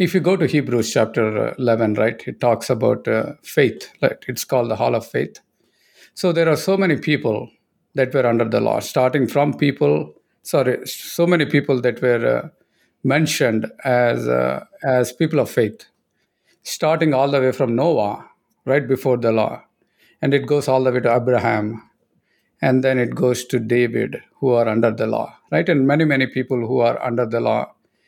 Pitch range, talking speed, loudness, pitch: 115-145 Hz, 185 wpm, -19 LUFS, 130 Hz